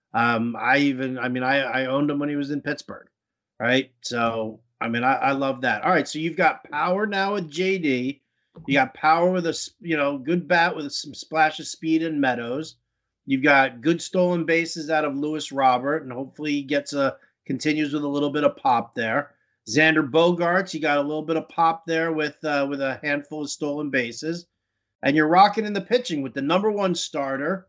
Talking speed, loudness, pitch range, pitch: 210 wpm, -23 LUFS, 135-165 Hz, 145 Hz